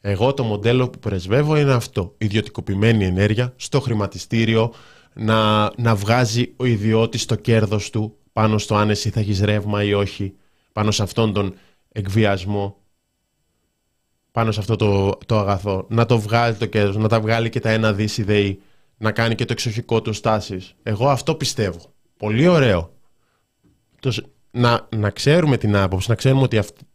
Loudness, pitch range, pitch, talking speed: -19 LUFS, 105-120 Hz, 110 Hz, 155 wpm